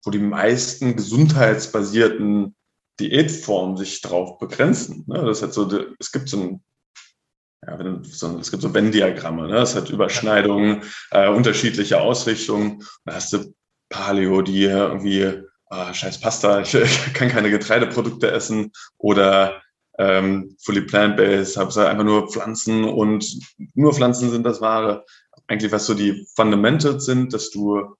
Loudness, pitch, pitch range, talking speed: -19 LUFS, 105 Hz, 100-115 Hz, 145 wpm